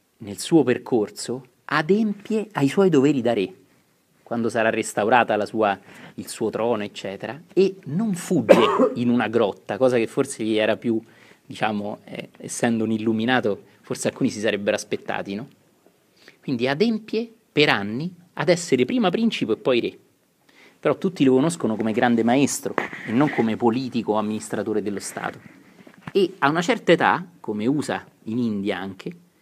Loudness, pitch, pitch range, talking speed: -22 LUFS, 125 Hz, 110-175 Hz, 155 wpm